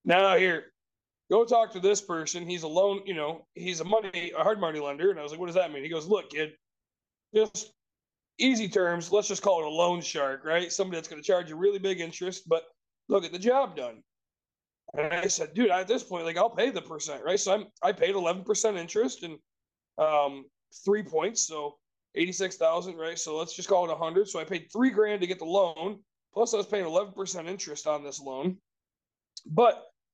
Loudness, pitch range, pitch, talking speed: -28 LUFS, 160-200 Hz, 180 Hz, 220 wpm